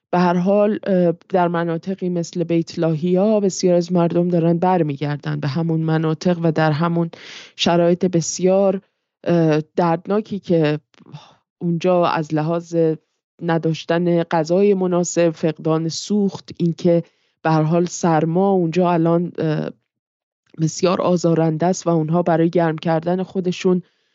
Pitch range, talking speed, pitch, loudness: 160-180 Hz, 115 wpm, 170 Hz, -19 LUFS